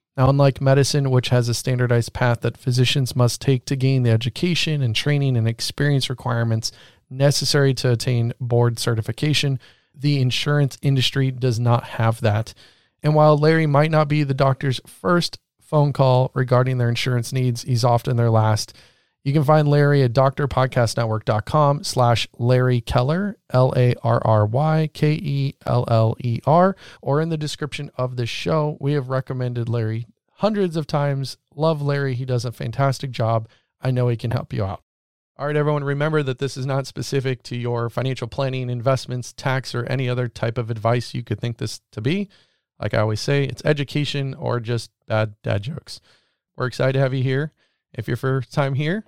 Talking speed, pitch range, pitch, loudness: 180 wpm, 120-140 Hz, 130 Hz, -21 LUFS